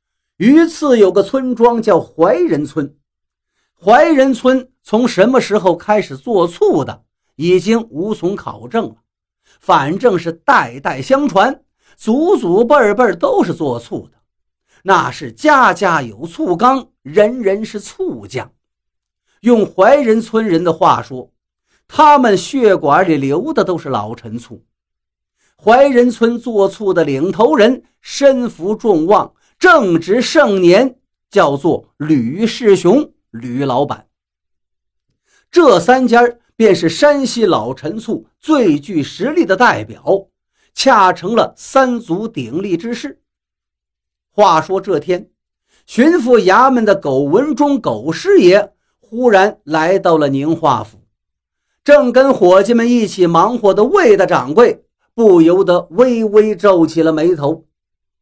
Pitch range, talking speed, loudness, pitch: 165-255 Hz, 180 characters per minute, -12 LUFS, 210 Hz